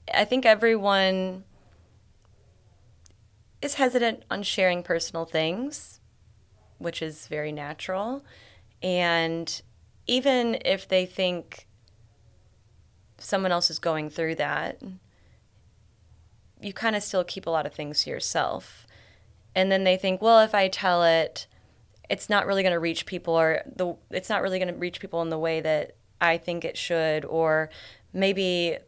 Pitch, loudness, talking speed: 165 Hz, -25 LUFS, 145 wpm